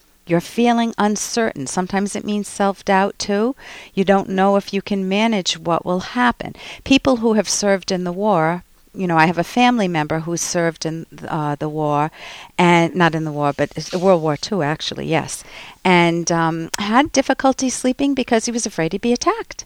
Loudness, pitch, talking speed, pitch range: -18 LUFS, 195 Hz, 185 wpm, 165-230 Hz